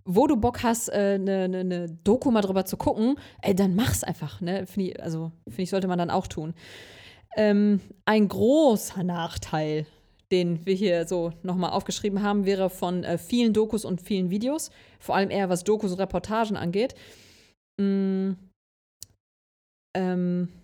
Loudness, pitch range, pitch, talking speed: -26 LUFS, 175-205 Hz, 190 Hz, 165 wpm